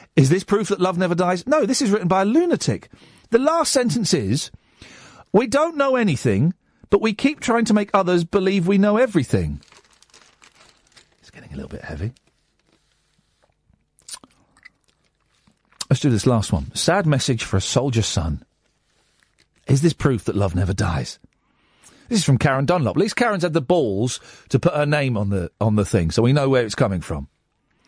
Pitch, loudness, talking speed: 150 Hz, -20 LUFS, 180 wpm